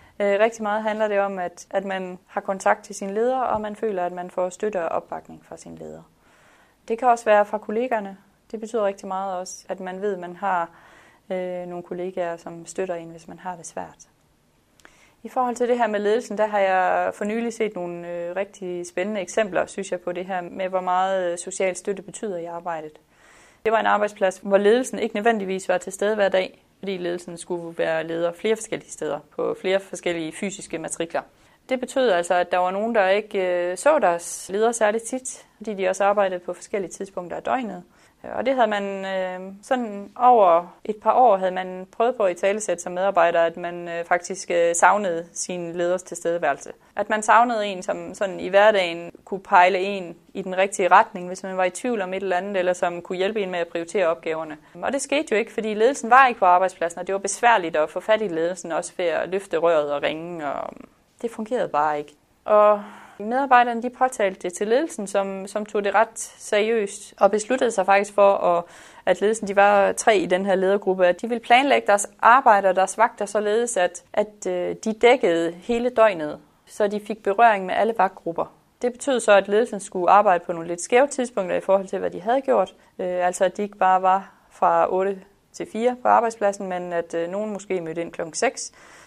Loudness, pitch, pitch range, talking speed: -22 LUFS, 195 Hz, 180-215 Hz, 210 wpm